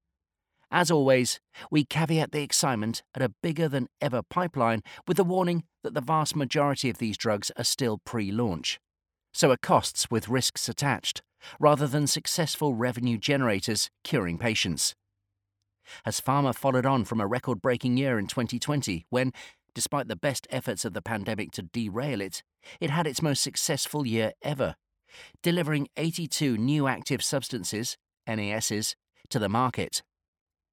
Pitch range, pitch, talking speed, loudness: 110-150 Hz, 125 Hz, 150 wpm, -28 LUFS